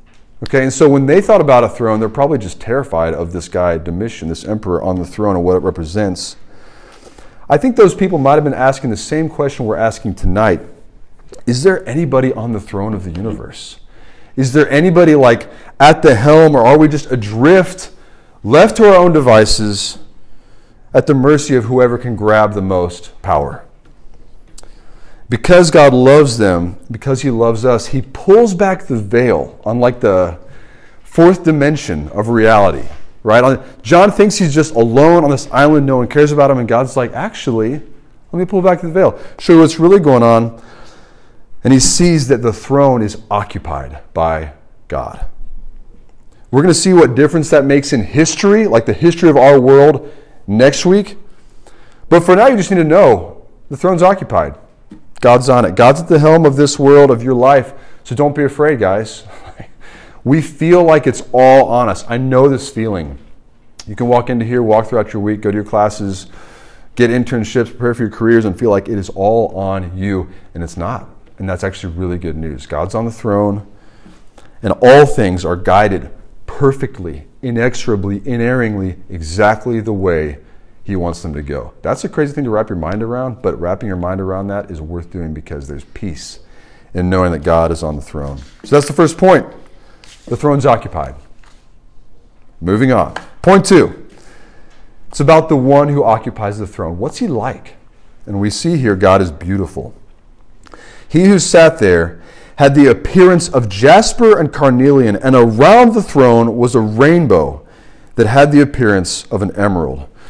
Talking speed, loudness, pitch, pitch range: 180 wpm, -11 LUFS, 120 Hz, 100-145 Hz